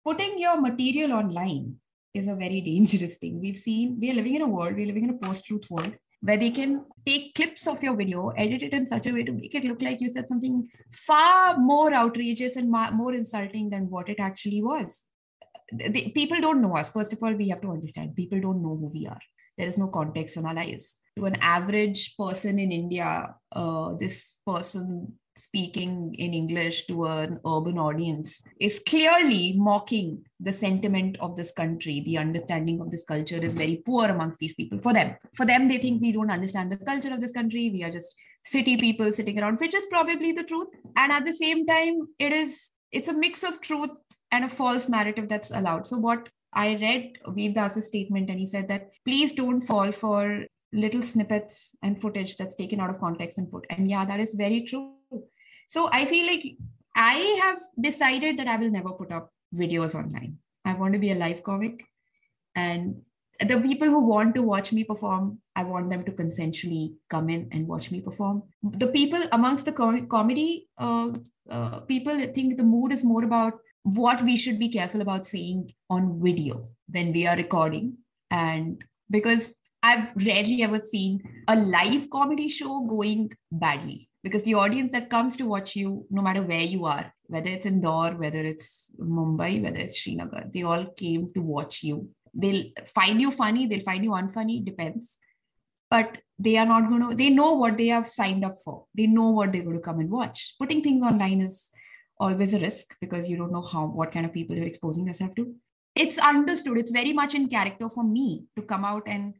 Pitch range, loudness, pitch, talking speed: 180-245 Hz, -26 LUFS, 210 Hz, 205 wpm